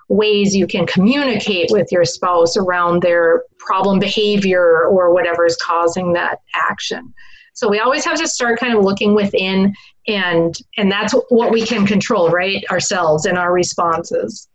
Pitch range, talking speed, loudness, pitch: 175-215 Hz, 160 wpm, -15 LUFS, 195 Hz